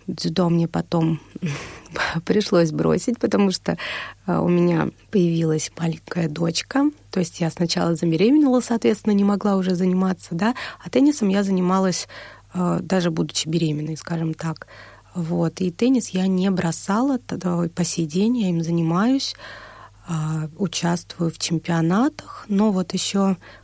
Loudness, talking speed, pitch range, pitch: -22 LUFS, 130 wpm, 165-200 Hz, 180 Hz